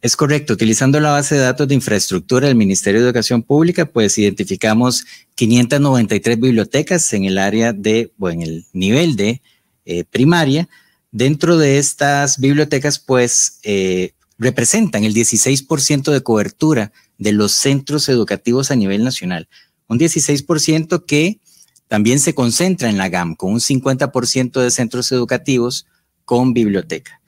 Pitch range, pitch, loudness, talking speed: 110-145 Hz, 125 Hz, -15 LUFS, 140 wpm